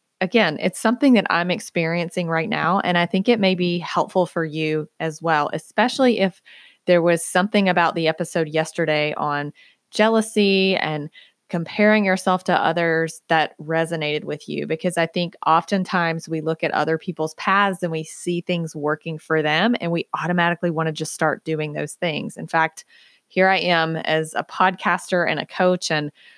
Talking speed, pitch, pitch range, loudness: 175 wpm, 170 Hz, 160-185 Hz, -21 LUFS